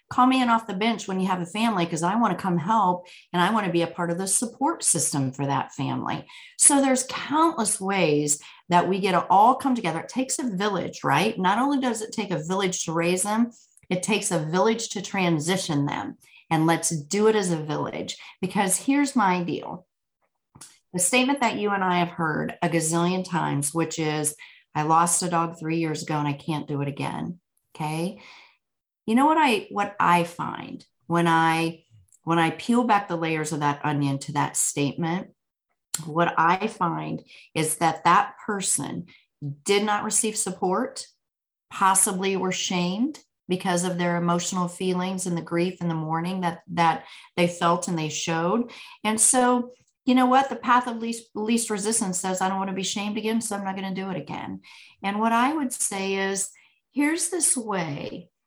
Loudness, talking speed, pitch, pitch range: -24 LUFS, 195 wpm, 185 Hz, 165-220 Hz